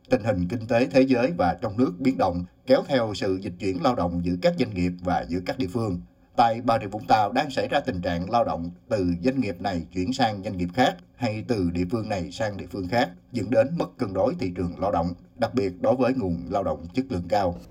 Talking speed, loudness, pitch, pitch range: 260 wpm, -25 LUFS, 95 Hz, 90-120 Hz